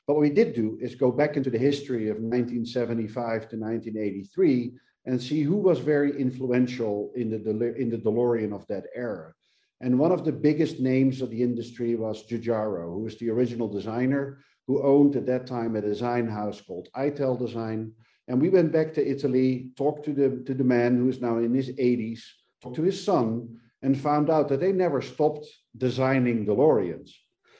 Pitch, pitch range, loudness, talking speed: 125 Hz, 115-140 Hz, -26 LUFS, 190 wpm